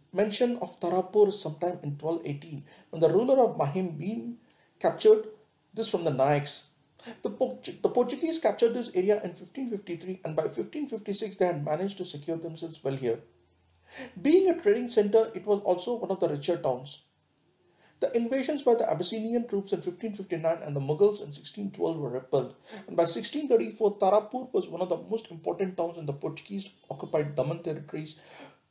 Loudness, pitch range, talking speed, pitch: -29 LUFS, 160-225 Hz, 170 wpm, 185 Hz